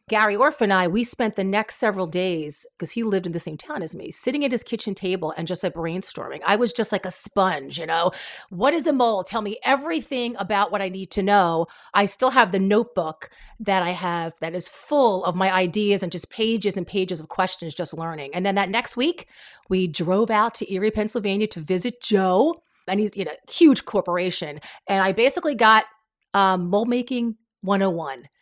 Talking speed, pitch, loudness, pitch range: 215 wpm, 200 Hz, -22 LUFS, 180-225 Hz